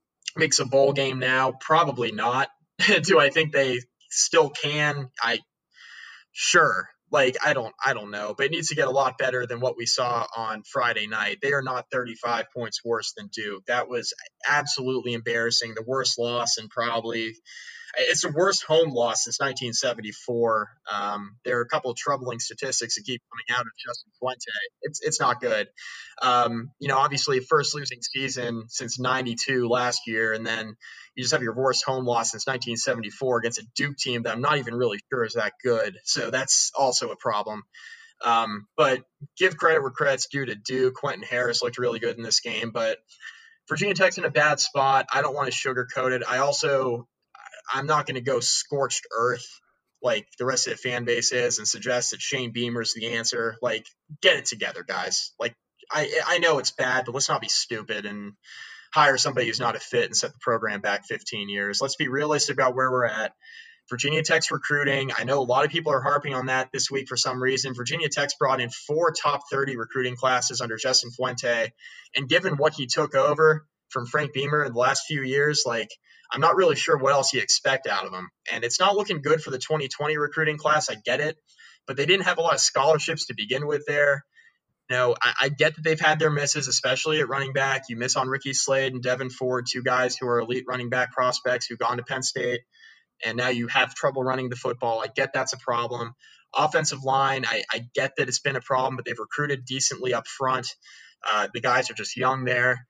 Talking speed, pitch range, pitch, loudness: 210 wpm, 120-145 Hz, 130 Hz, -24 LUFS